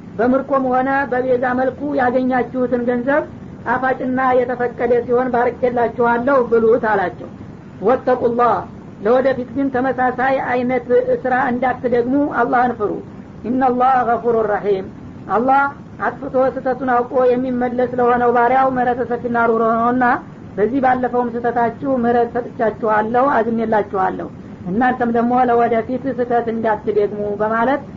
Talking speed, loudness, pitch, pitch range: 100 wpm, -17 LUFS, 245 Hz, 235-255 Hz